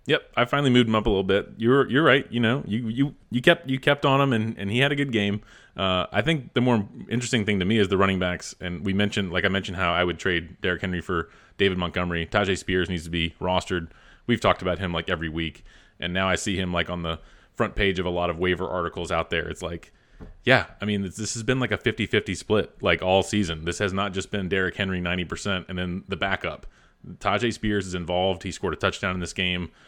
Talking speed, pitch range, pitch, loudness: 255 wpm, 90-110 Hz, 95 Hz, -25 LUFS